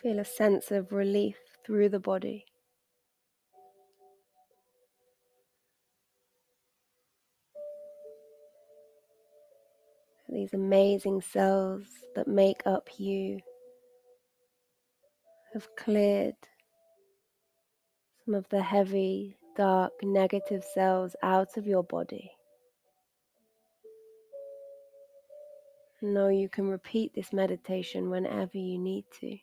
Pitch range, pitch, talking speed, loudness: 195-295 Hz, 210 Hz, 75 wpm, -30 LUFS